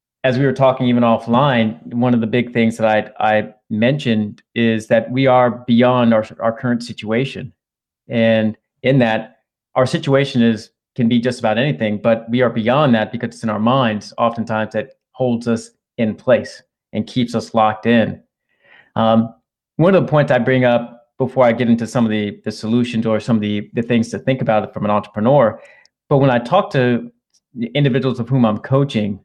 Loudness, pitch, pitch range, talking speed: -17 LUFS, 115 Hz, 110-125 Hz, 200 wpm